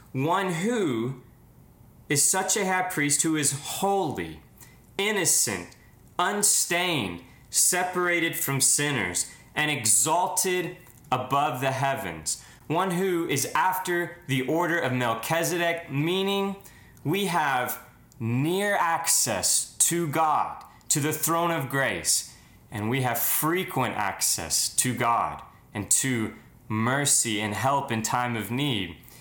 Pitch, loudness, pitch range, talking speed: 145 Hz, -25 LUFS, 120-175 Hz, 115 wpm